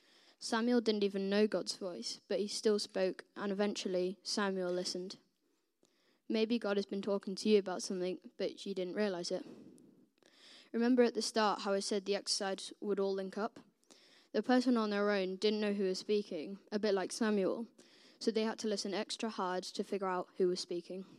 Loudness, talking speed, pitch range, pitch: -36 LUFS, 195 wpm, 190-225 Hz, 205 Hz